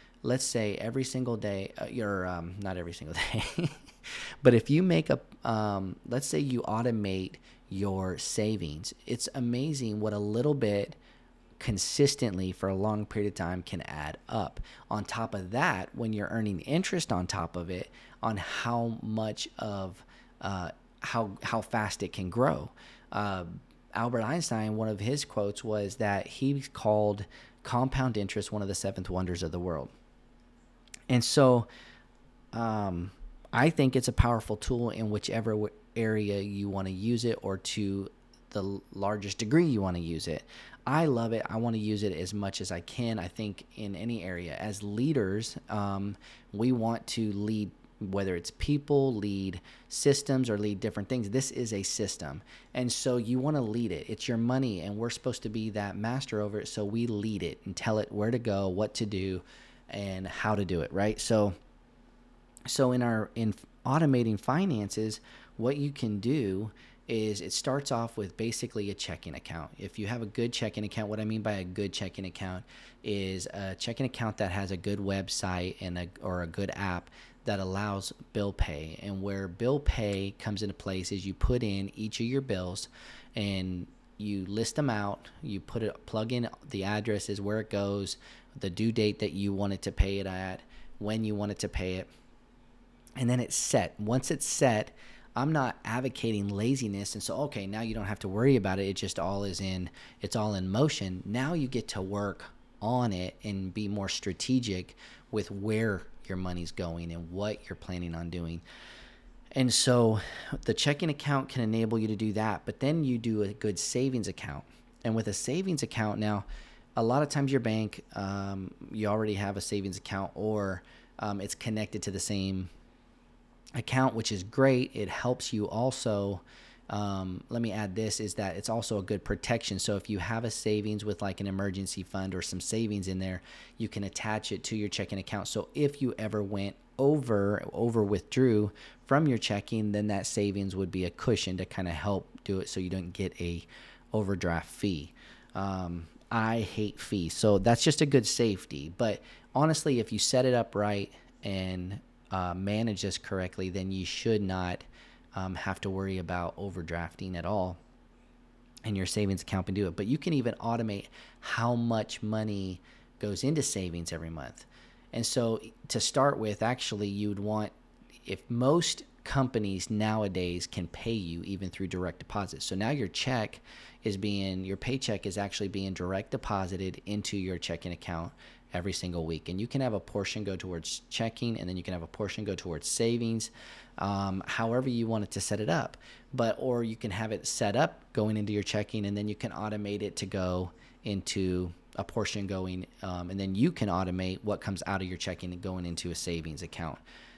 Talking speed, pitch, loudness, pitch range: 190 wpm, 105 Hz, -32 LUFS, 95-115 Hz